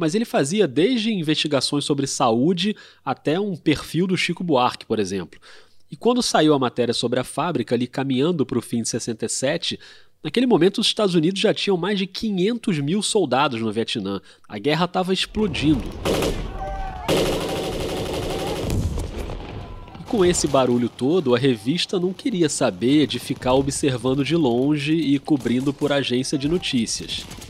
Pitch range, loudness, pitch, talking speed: 120-180 Hz, -21 LUFS, 145 Hz, 150 wpm